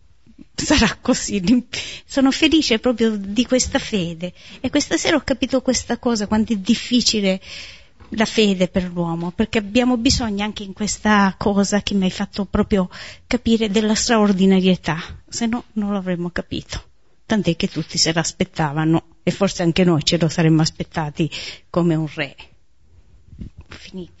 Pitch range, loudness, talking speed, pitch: 170-230 Hz, -19 LUFS, 145 wpm, 200 Hz